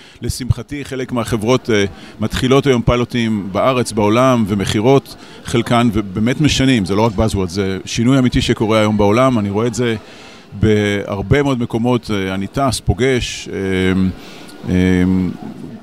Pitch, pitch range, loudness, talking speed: 115 Hz, 100-125 Hz, -16 LUFS, 135 wpm